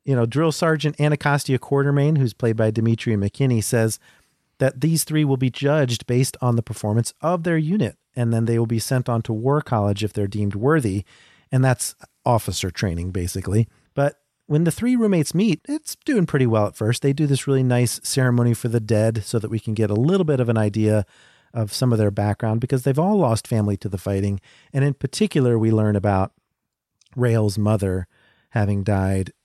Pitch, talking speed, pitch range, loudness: 120 Hz, 200 wpm, 110-145 Hz, -21 LUFS